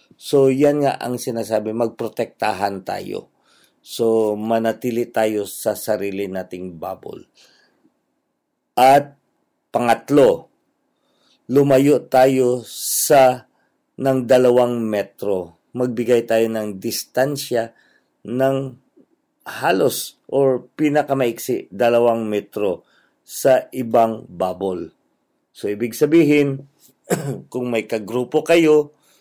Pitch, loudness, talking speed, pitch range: 125 Hz, -19 LUFS, 85 wpm, 110-140 Hz